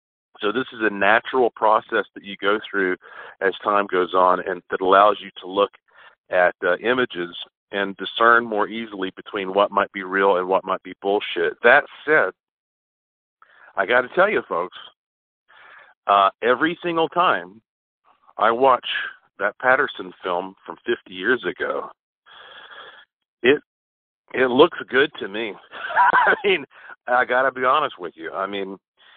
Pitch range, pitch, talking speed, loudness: 95-130 Hz, 100 Hz, 155 wpm, -20 LUFS